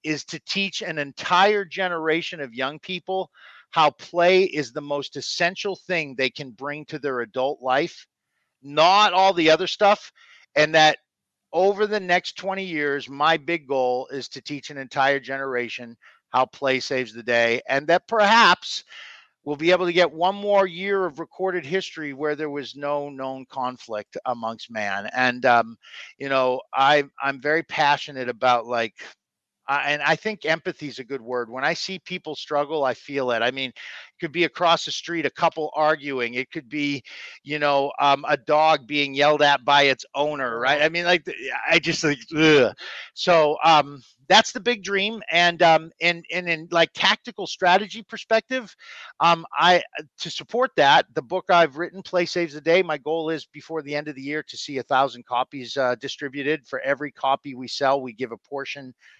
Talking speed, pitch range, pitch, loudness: 185 wpm, 135-175 Hz, 150 Hz, -22 LUFS